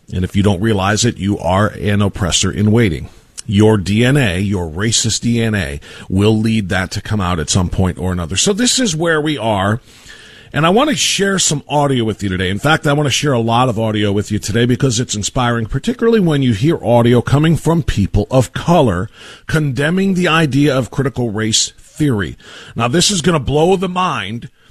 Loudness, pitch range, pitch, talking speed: -15 LUFS, 105-145 Hz, 115 Hz, 205 wpm